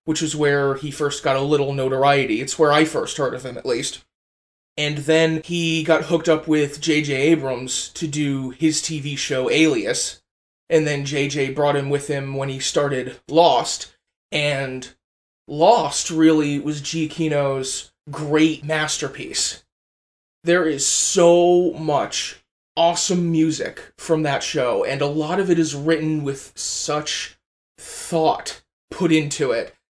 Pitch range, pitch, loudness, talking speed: 140-160 Hz, 150 Hz, -20 LUFS, 145 wpm